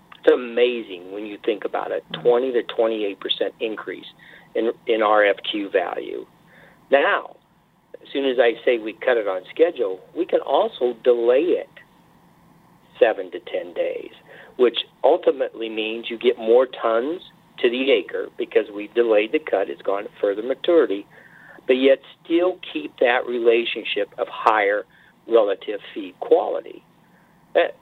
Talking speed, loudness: 145 wpm, -21 LUFS